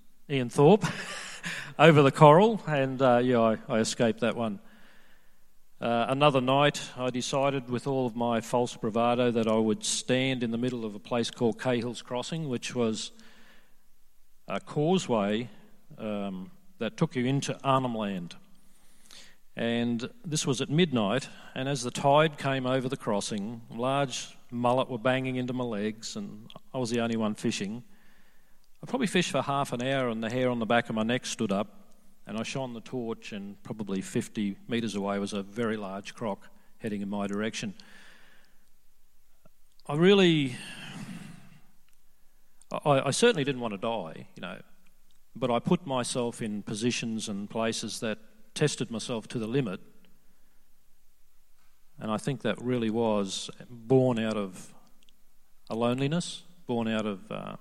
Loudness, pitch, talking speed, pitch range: -28 LUFS, 130 Hz, 160 wpm, 115-170 Hz